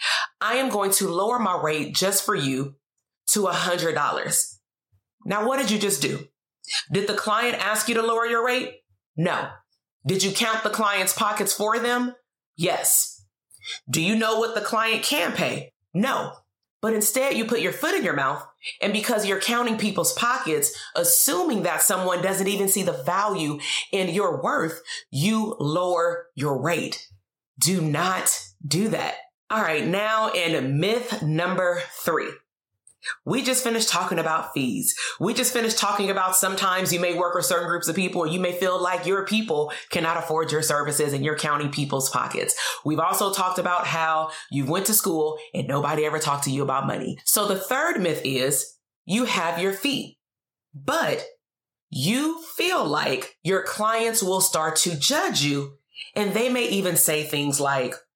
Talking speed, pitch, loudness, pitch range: 175 wpm, 185 Hz, -23 LUFS, 155-220 Hz